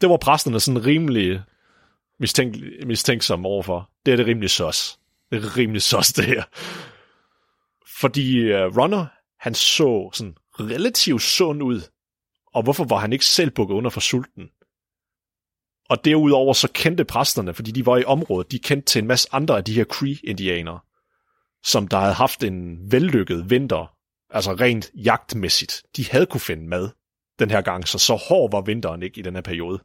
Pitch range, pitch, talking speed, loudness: 95-130 Hz, 115 Hz, 175 wpm, -20 LUFS